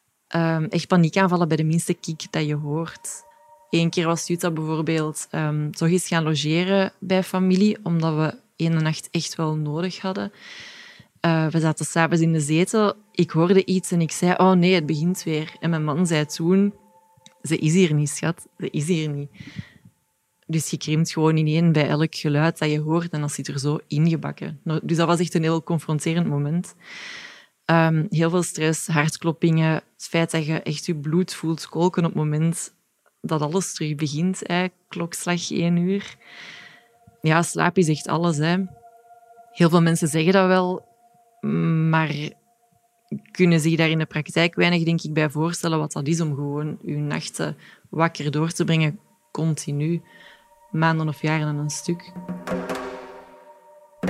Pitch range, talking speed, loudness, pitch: 155-185 Hz, 175 wpm, -22 LUFS, 165 Hz